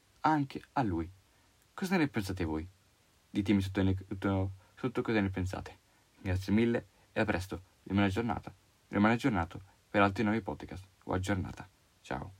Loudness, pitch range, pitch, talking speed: -33 LUFS, 95-105 Hz, 100 Hz, 155 wpm